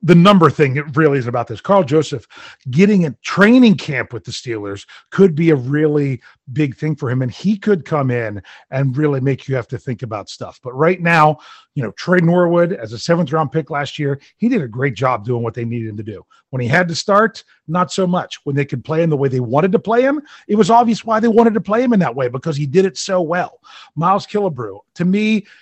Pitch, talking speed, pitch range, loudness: 155 Hz, 250 wpm, 130-190 Hz, -16 LUFS